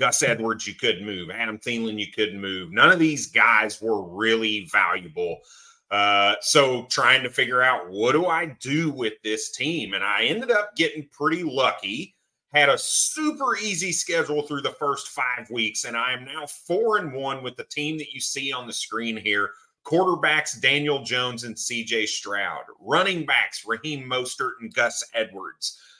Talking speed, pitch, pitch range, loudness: 180 wpm, 130 Hz, 115-160 Hz, -23 LUFS